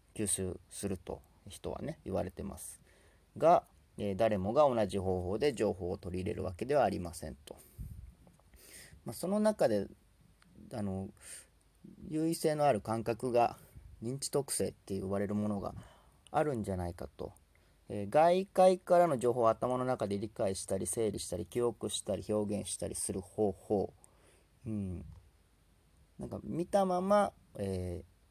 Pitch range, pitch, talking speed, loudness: 95-125 Hz, 105 Hz, 280 characters per minute, -34 LUFS